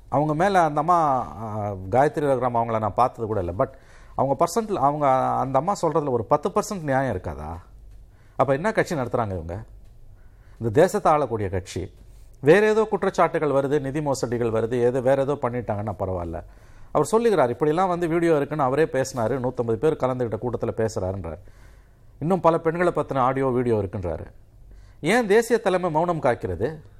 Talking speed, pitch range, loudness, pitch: 155 wpm, 105-155 Hz, -23 LUFS, 130 Hz